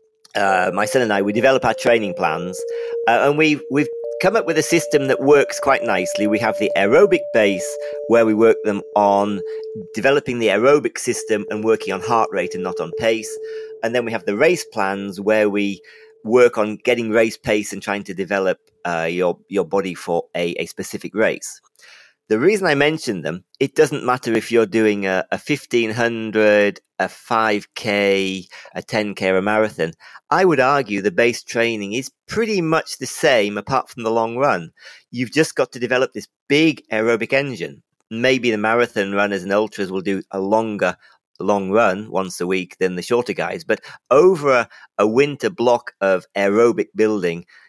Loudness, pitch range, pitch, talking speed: -19 LUFS, 100-145 Hz, 115 Hz, 185 wpm